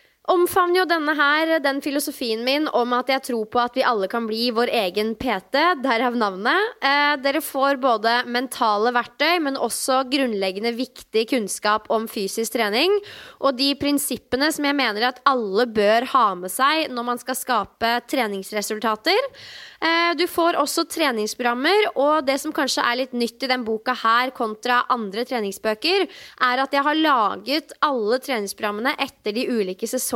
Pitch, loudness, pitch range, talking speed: 255 Hz, -21 LUFS, 230-290 Hz, 165 wpm